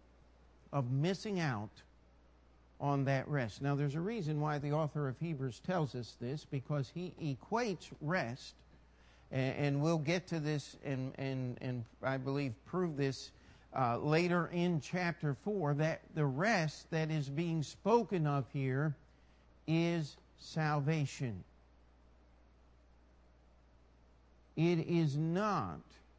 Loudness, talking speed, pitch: -37 LUFS, 120 wpm, 140 Hz